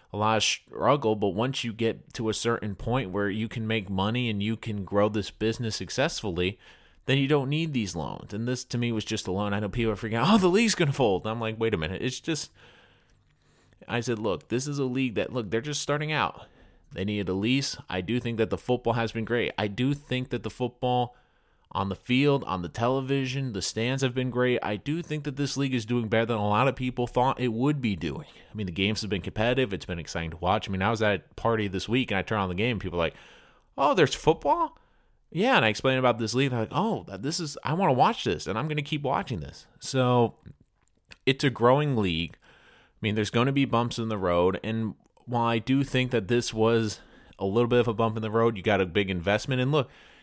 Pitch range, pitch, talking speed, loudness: 105-130 Hz, 115 Hz, 260 wpm, -27 LUFS